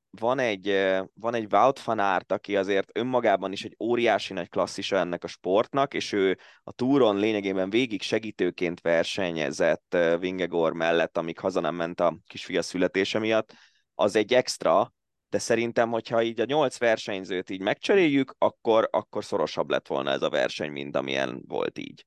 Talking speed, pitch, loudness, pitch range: 165 wpm, 95 Hz, -26 LUFS, 85-110 Hz